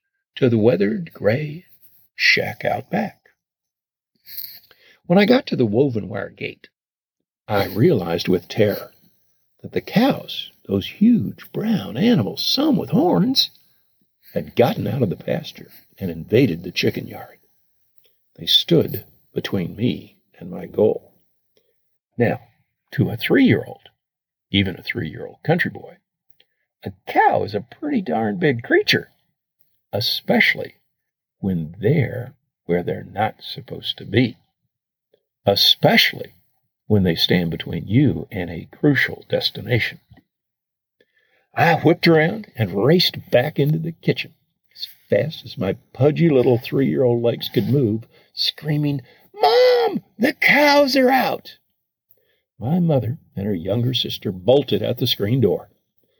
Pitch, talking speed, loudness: 145 Hz, 135 wpm, -19 LUFS